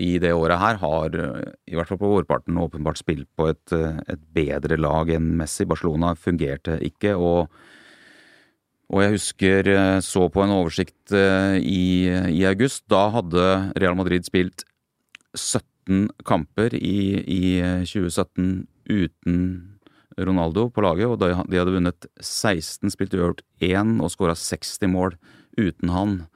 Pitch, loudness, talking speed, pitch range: 90 Hz, -22 LUFS, 140 wpm, 85-95 Hz